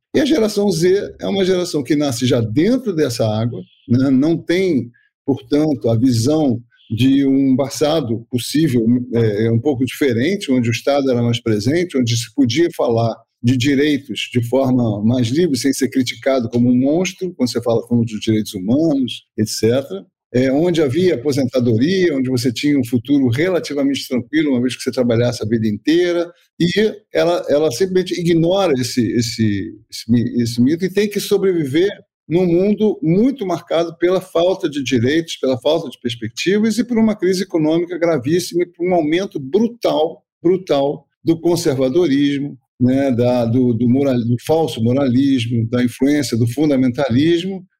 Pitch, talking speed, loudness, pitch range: 140 Hz, 160 wpm, -17 LUFS, 120-175 Hz